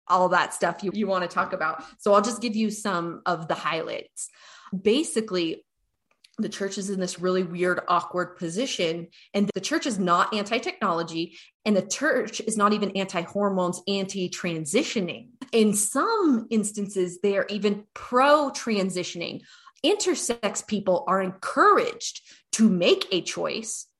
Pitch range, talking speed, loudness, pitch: 180-225 Hz, 155 wpm, -25 LUFS, 200 Hz